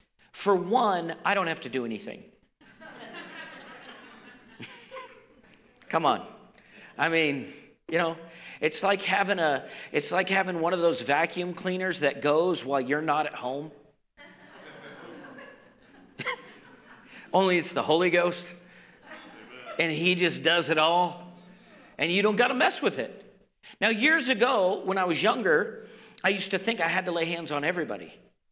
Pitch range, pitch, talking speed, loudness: 165-220 Hz, 180 Hz, 145 wpm, -26 LUFS